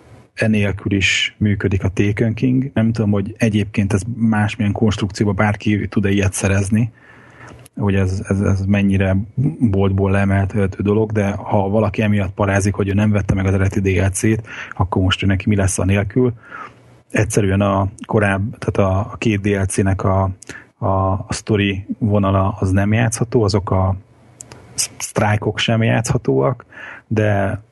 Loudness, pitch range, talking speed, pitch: -18 LUFS, 100-110 Hz, 145 wpm, 105 Hz